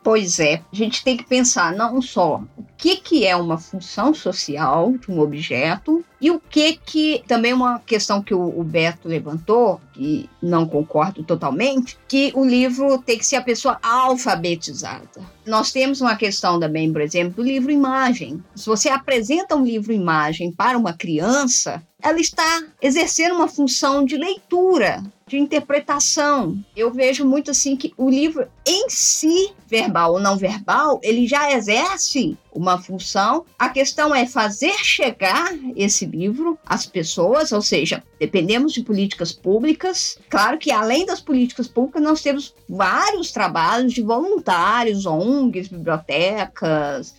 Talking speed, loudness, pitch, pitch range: 155 wpm, -19 LUFS, 245 Hz, 190-285 Hz